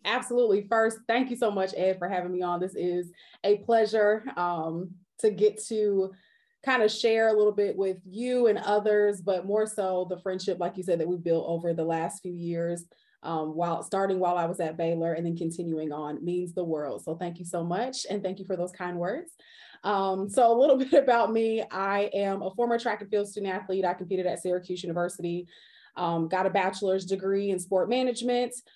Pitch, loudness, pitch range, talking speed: 190 Hz, -28 LUFS, 175-215 Hz, 210 wpm